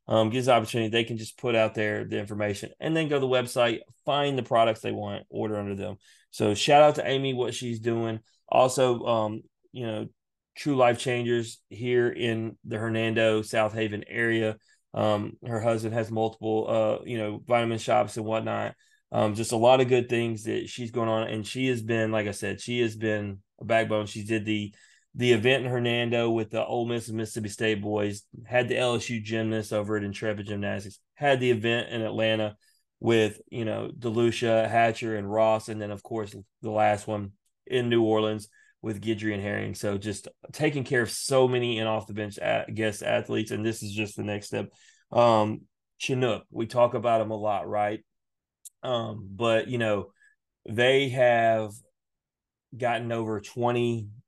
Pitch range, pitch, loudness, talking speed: 105-120 Hz, 110 Hz, -27 LUFS, 185 wpm